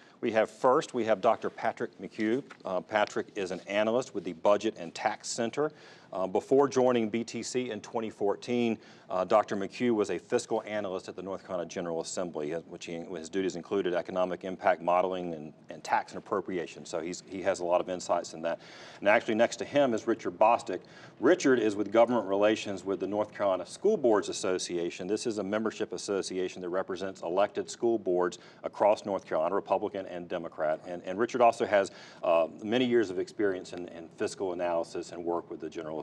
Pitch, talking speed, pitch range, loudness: 100 Hz, 195 wpm, 90-115 Hz, -30 LUFS